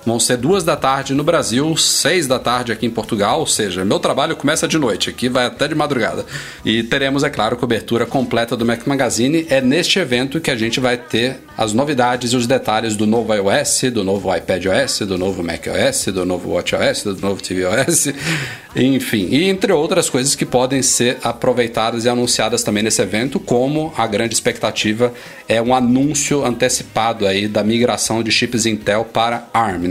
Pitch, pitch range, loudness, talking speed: 120 Hz, 110-135 Hz, -16 LUFS, 185 wpm